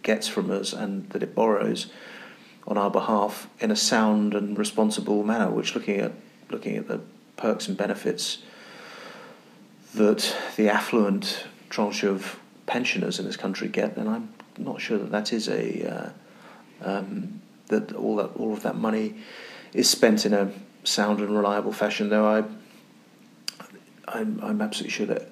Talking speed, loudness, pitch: 160 wpm, -26 LUFS, 110 Hz